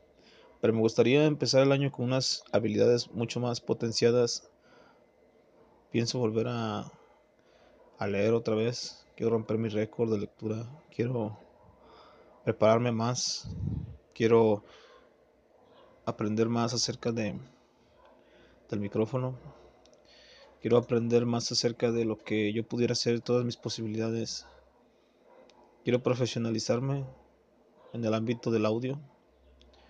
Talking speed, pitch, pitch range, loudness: 110 wpm, 115 Hz, 110-120 Hz, -30 LUFS